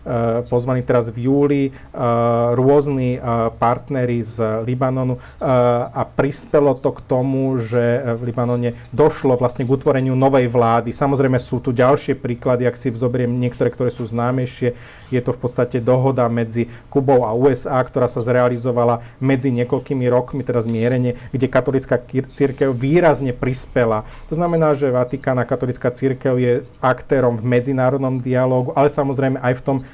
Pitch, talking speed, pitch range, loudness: 125 Hz, 145 wpm, 120-135 Hz, -18 LUFS